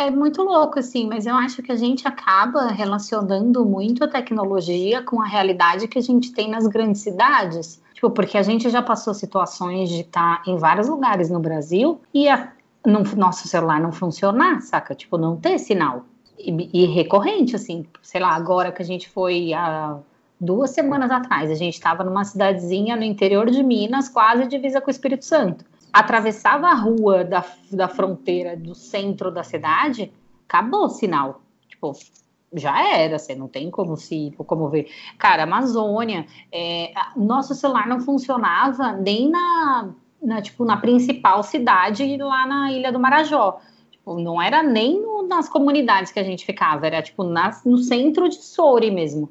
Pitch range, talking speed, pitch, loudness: 180-260 Hz, 175 wpm, 210 Hz, -19 LUFS